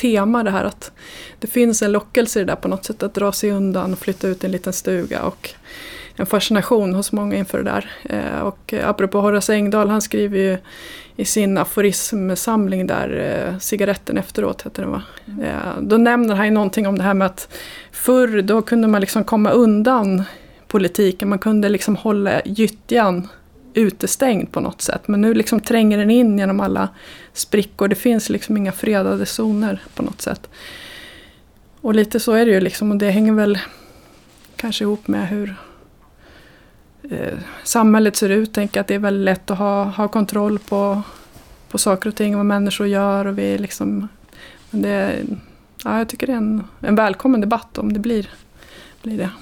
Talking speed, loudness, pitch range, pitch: 185 wpm, -18 LUFS, 195-220 Hz, 205 Hz